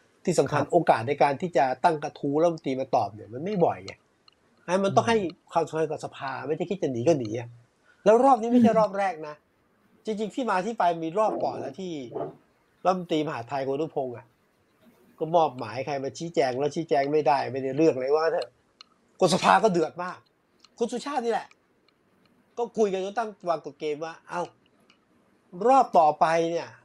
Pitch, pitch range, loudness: 165 Hz, 150-210 Hz, -26 LUFS